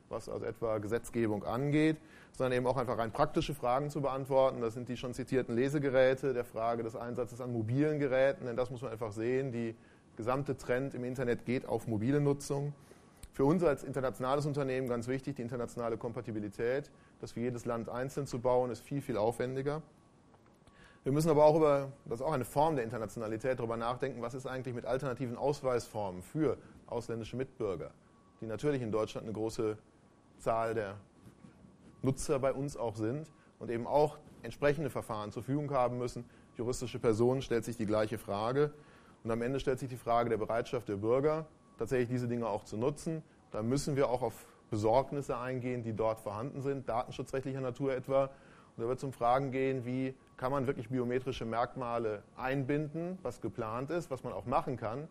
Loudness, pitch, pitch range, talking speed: -35 LUFS, 125 Hz, 115-135 Hz, 185 wpm